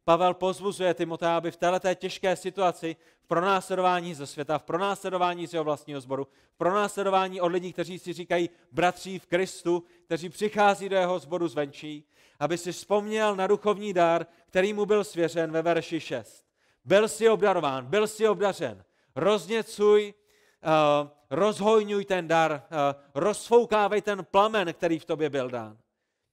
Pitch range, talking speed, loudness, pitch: 165-200 Hz, 150 wpm, -27 LUFS, 180 Hz